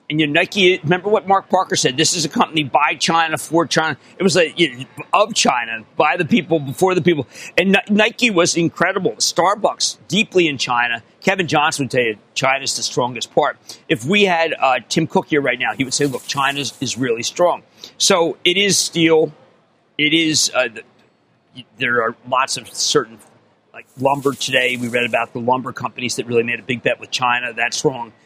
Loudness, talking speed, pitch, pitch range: -17 LUFS, 200 wpm, 155 Hz, 125-175 Hz